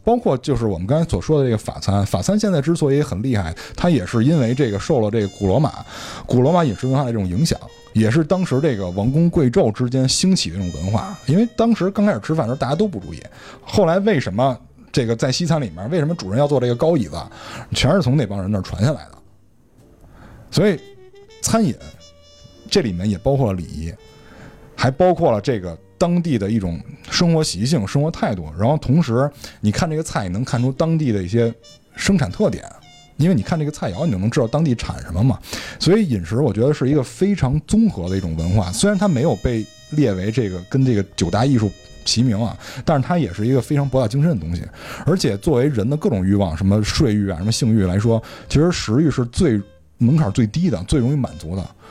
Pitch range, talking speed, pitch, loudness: 105-155 Hz, 335 characters per minute, 125 Hz, -19 LUFS